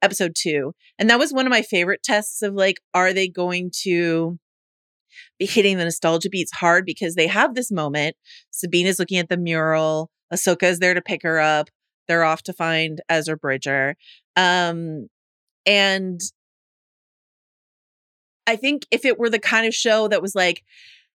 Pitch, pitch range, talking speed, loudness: 180 Hz, 165-200 Hz, 170 wpm, -20 LUFS